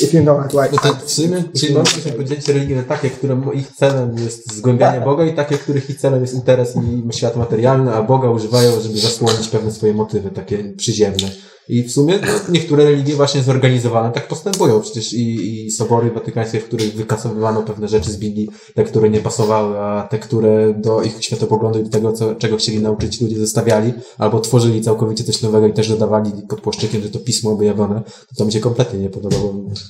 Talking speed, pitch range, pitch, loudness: 190 wpm, 110-130 Hz, 115 Hz, -16 LUFS